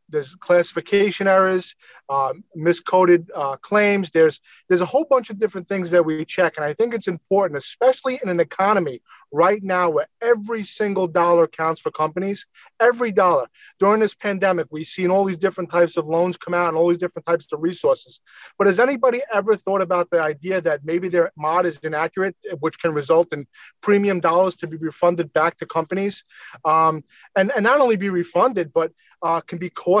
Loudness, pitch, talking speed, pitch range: -20 LUFS, 180 Hz, 190 wpm, 165-200 Hz